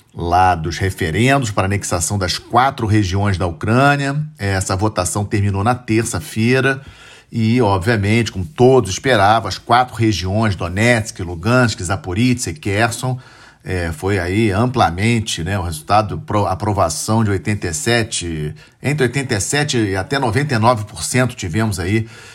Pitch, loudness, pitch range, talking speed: 110 Hz, -17 LUFS, 95-120 Hz, 125 wpm